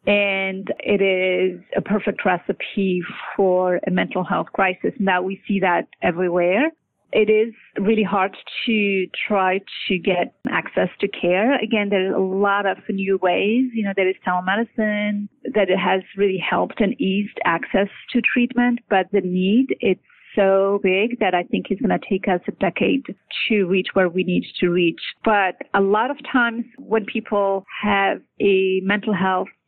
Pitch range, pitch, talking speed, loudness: 185-215 Hz, 200 Hz, 170 wpm, -20 LUFS